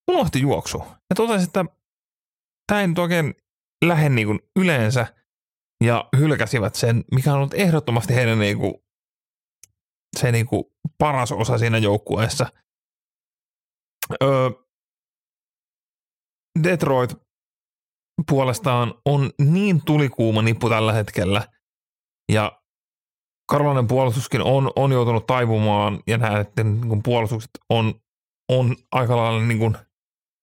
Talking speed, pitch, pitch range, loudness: 100 wpm, 125 Hz, 110-145 Hz, -20 LUFS